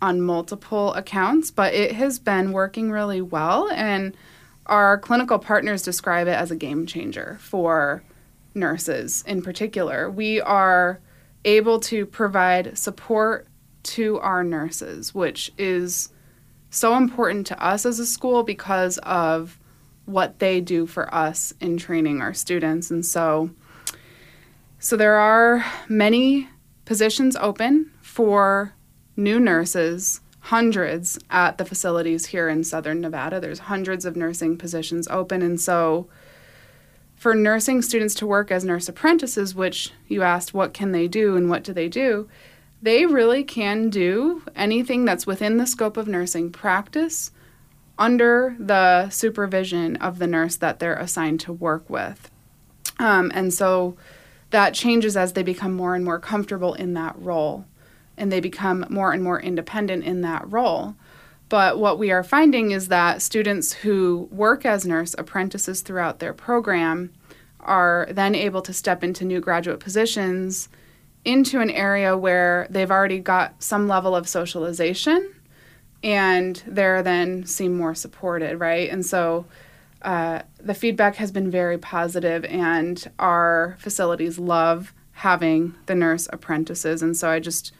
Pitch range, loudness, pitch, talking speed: 170-210 Hz, -21 LUFS, 185 Hz, 145 wpm